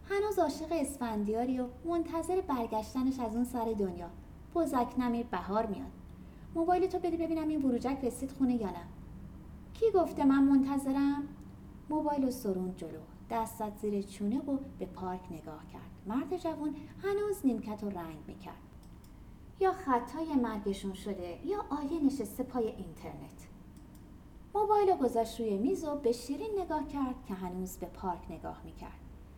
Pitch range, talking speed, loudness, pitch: 215-310 Hz, 145 wpm, -34 LUFS, 255 Hz